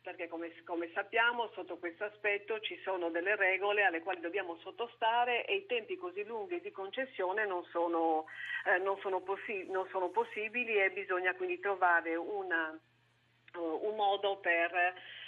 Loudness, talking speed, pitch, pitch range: -34 LUFS, 160 wpm, 190 Hz, 170-225 Hz